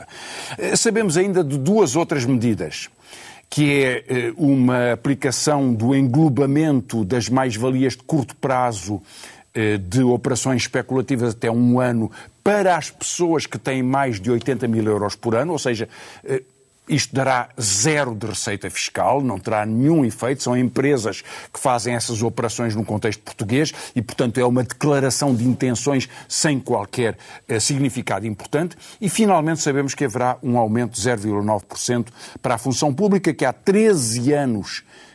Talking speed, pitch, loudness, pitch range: 145 wpm, 130 Hz, -20 LUFS, 115-145 Hz